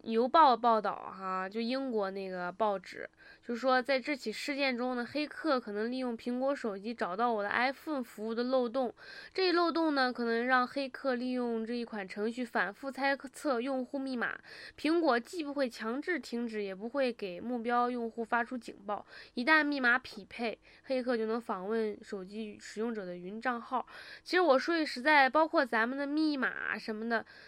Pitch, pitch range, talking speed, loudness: 245 Hz, 225-275 Hz, 285 characters per minute, -32 LUFS